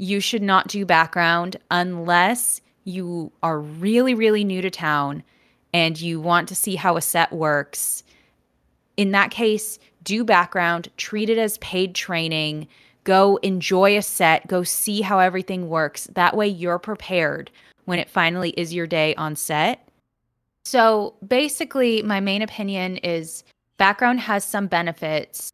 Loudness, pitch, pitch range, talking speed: -21 LUFS, 185 Hz, 170-205 Hz, 150 wpm